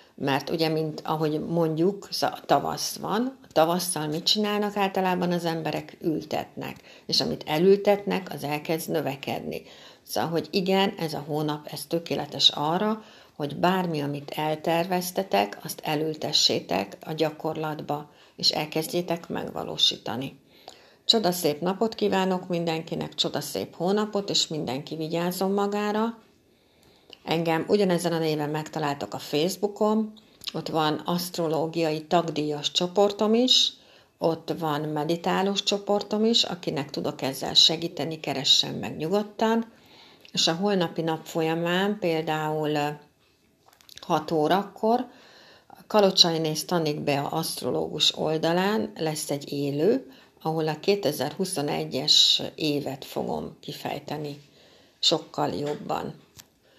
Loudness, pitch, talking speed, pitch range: -25 LUFS, 165 Hz, 110 wpm, 155-195 Hz